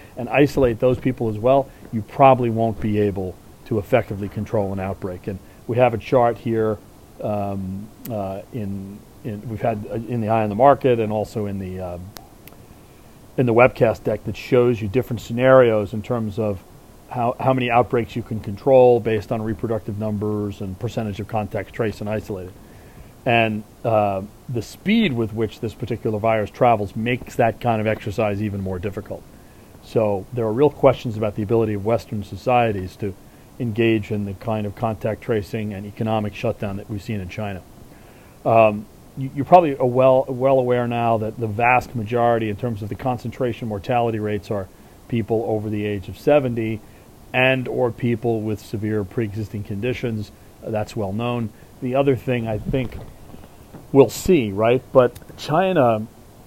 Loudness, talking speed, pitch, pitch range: -21 LUFS, 175 wpm, 110 Hz, 105-120 Hz